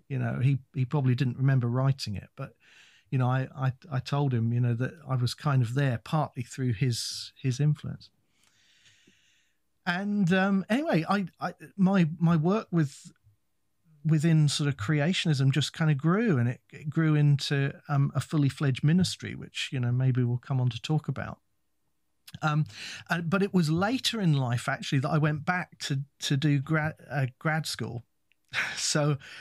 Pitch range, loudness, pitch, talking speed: 130-160 Hz, -28 LUFS, 145 Hz, 180 wpm